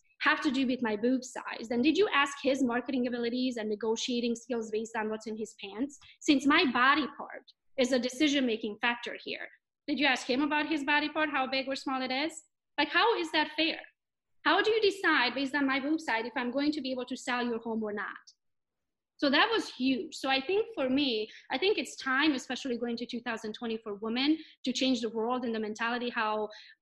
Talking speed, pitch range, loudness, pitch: 225 wpm, 235-295 Hz, -30 LUFS, 260 Hz